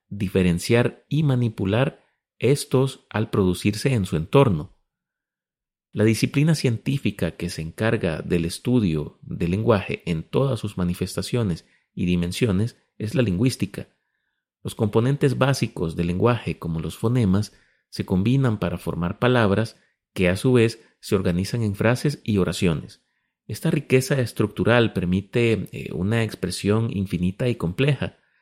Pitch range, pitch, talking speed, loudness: 90-125 Hz, 110 Hz, 125 wpm, -23 LUFS